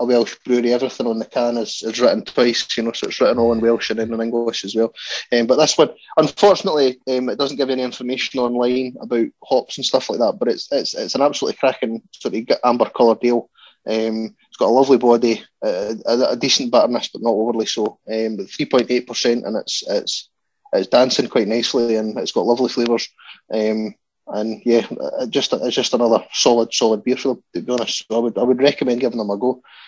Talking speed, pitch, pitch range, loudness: 220 wpm, 120 Hz, 110-125 Hz, -18 LUFS